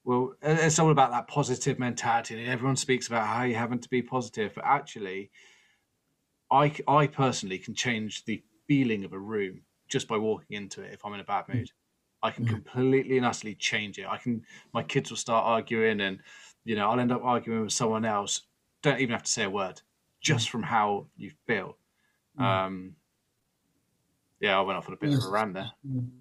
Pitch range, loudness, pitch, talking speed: 110-130 Hz, -28 LUFS, 120 Hz, 200 wpm